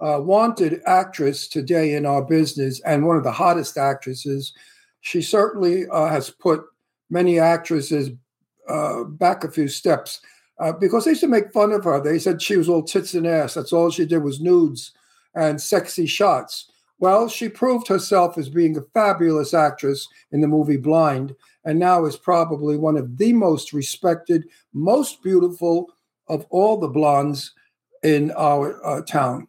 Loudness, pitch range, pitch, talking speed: -20 LUFS, 150-185 Hz, 165 Hz, 170 wpm